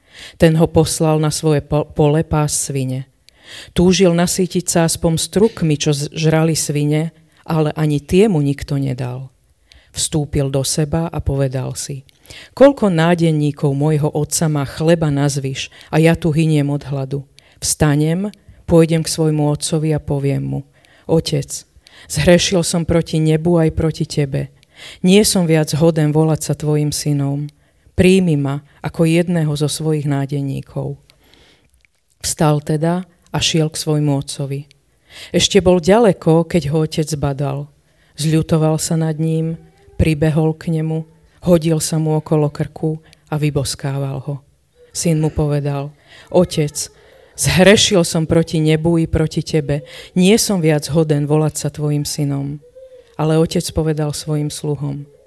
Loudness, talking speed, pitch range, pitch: -16 LUFS, 135 wpm, 145-165 Hz, 155 Hz